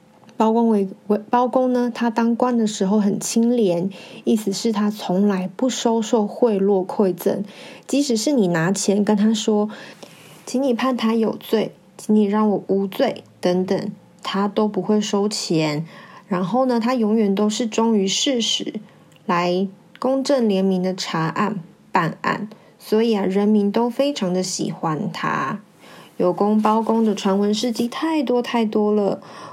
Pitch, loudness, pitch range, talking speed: 210 Hz, -20 LUFS, 195-230 Hz, 215 characters per minute